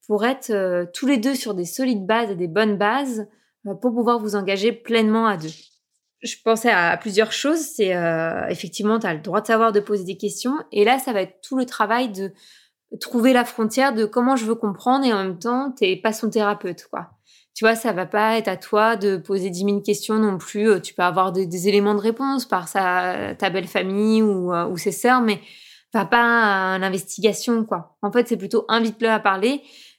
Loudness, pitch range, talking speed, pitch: -21 LUFS, 195-230 Hz, 220 wpm, 215 Hz